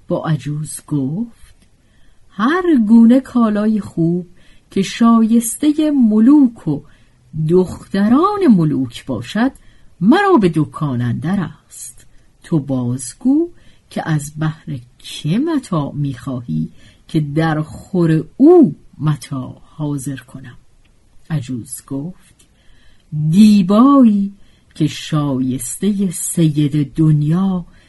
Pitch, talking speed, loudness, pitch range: 160 Hz, 85 wpm, -15 LUFS, 140-215 Hz